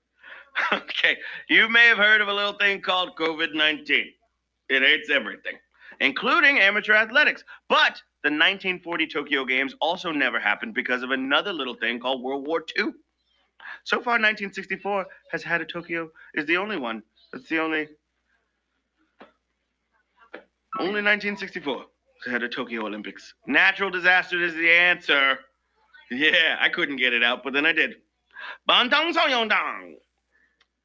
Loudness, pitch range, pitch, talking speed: -22 LUFS, 145-210 Hz, 175 Hz, 140 wpm